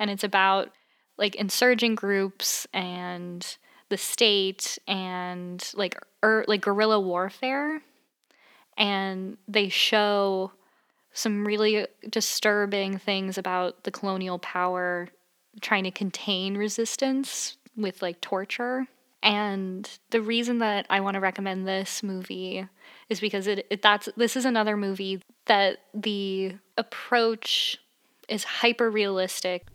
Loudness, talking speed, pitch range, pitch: -26 LUFS, 115 wpm, 190-220 Hz, 200 Hz